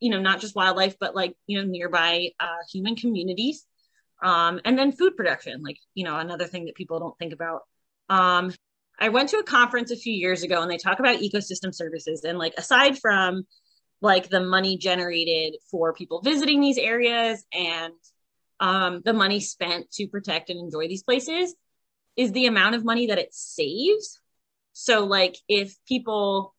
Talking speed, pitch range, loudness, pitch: 180 wpm, 175-235 Hz, -23 LUFS, 190 Hz